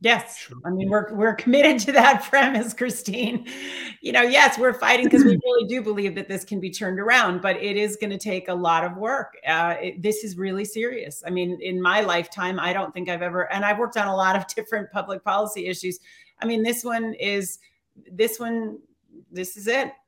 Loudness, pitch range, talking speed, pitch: -22 LUFS, 185-235 Hz, 220 wpm, 210 Hz